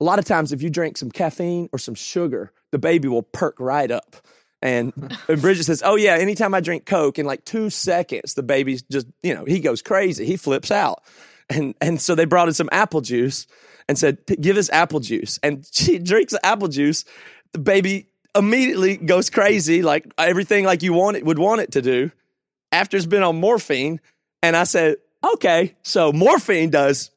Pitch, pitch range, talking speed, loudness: 170 Hz, 145-195 Hz, 205 wpm, -19 LUFS